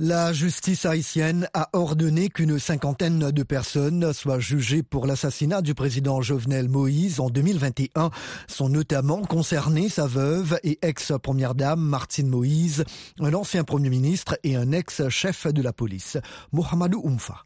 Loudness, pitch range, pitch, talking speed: -24 LUFS, 135-165 Hz, 150 Hz, 145 wpm